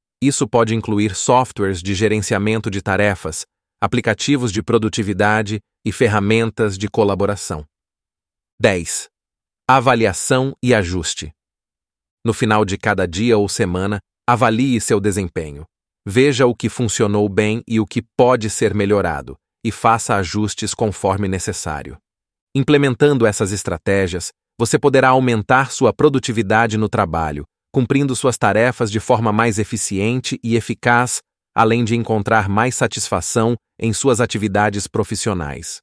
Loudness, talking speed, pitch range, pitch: -17 LUFS, 120 wpm, 100-120 Hz, 110 Hz